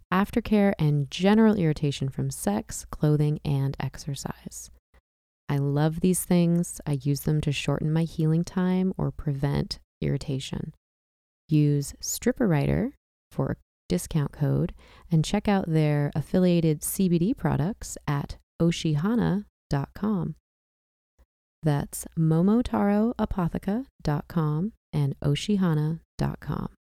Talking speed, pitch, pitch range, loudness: 95 wpm, 155 Hz, 140-185 Hz, -26 LUFS